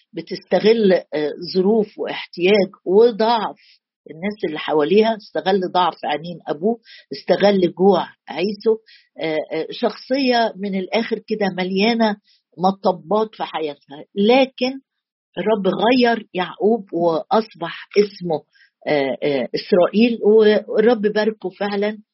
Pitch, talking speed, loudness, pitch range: 205 Hz, 85 wpm, -19 LUFS, 180-220 Hz